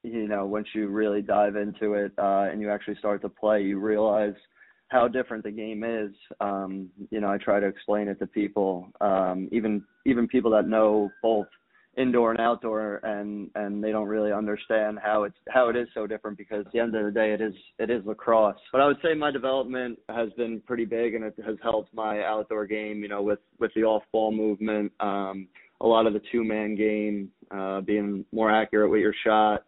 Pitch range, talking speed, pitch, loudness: 105-110 Hz, 215 wpm, 105 Hz, -26 LUFS